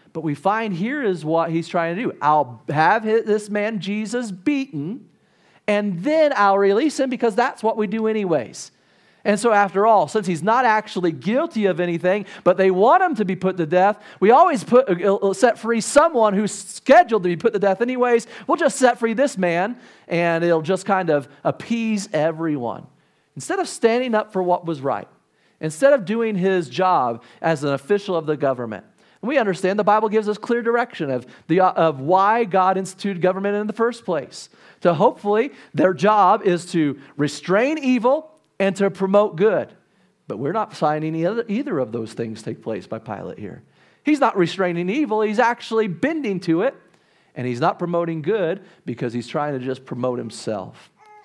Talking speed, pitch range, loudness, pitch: 185 wpm, 170-225 Hz, -20 LUFS, 195 Hz